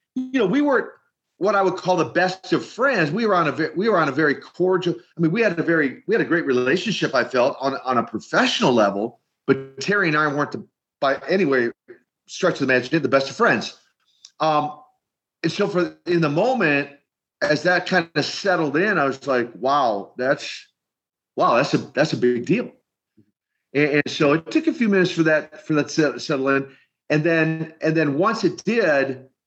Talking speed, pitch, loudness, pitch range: 215 wpm, 160 Hz, -21 LUFS, 145-180 Hz